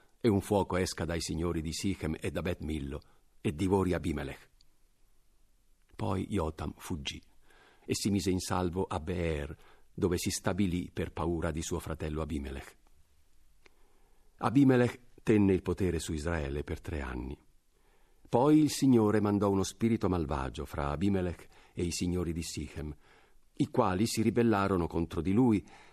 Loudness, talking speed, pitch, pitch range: -31 LUFS, 145 wpm, 90 Hz, 80-100 Hz